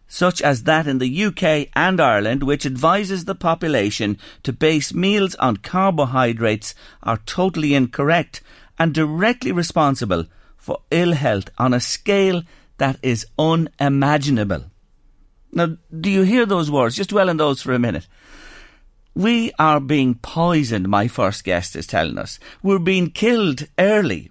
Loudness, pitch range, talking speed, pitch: -19 LUFS, 130-180 Hz, 145 wpm, 155 Hz